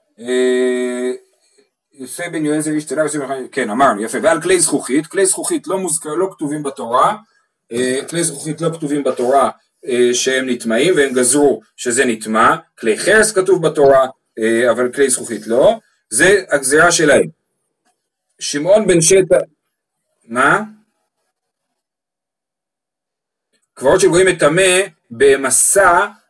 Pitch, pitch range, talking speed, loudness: 155 Hz, 130-190 Hz, 105 wpm, -14 LUFS